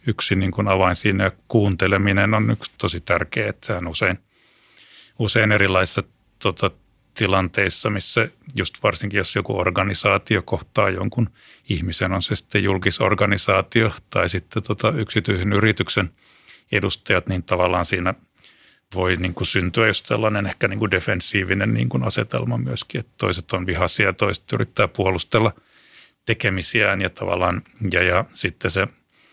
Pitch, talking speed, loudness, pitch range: 100 Hz, 120 wpm, -21 LUFS, 95-105 Hz